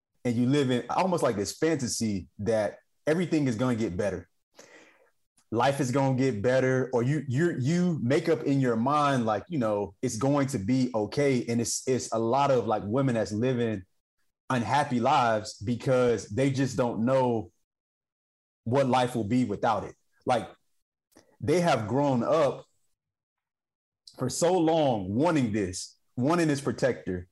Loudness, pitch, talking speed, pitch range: -27 LUFS, 125 Hz, 165 wpm, 110-140 Hz